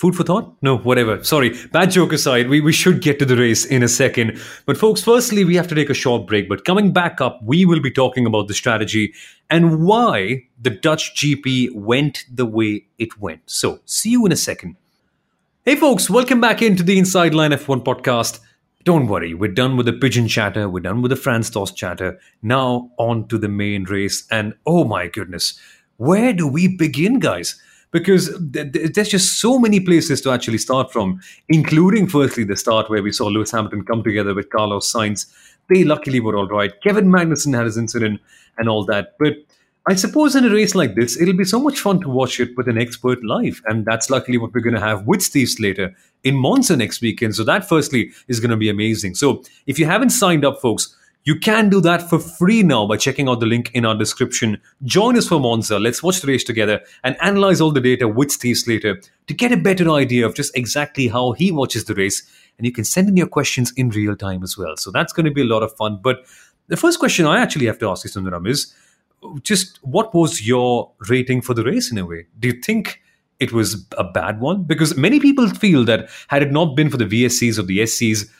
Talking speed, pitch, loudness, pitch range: 225 wpm, 130 Hz, -17 LUFS, 110-170 Hz